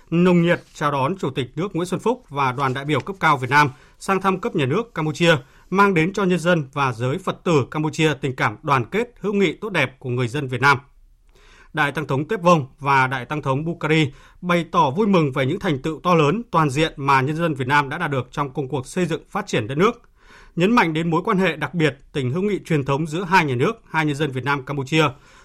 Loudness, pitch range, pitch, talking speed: -20 LUFS, 140-180 Hz, 155 Hz, 255 wpm